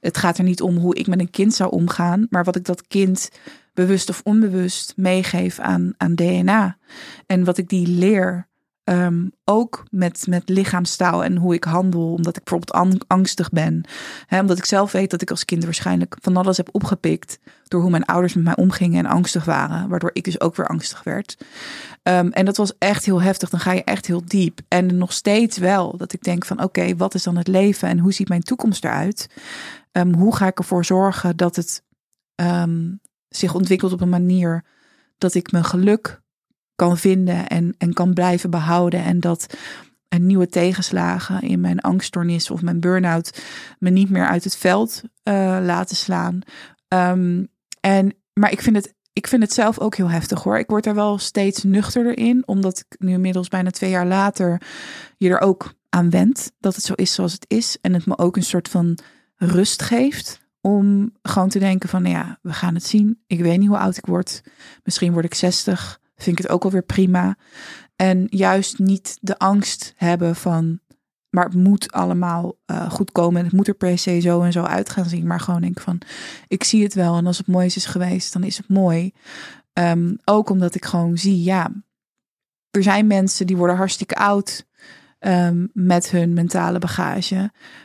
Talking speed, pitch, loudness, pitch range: 200 wpm, 185 Hz, -19 LUFS, 175-195 Hz